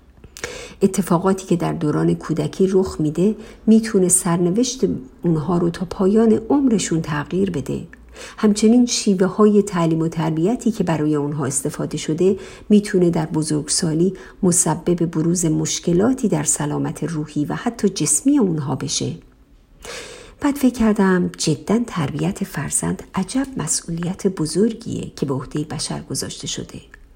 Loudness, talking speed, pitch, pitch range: -19 LUFS, 125 wpm, 175 Hz, 155-205 Hz